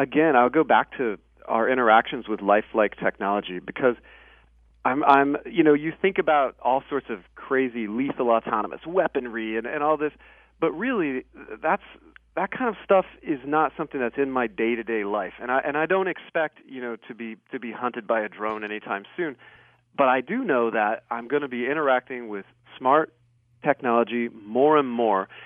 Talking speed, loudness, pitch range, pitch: 190 wpm, -24 LUFS, 110-145 Hz, 120 Hz